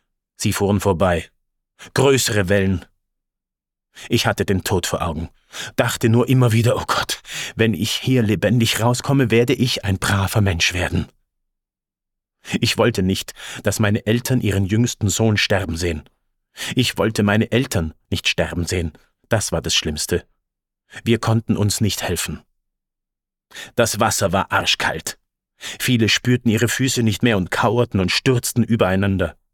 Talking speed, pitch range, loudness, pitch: 140 wpm, 95-115 Hz, -19 LUFS, 105 Hz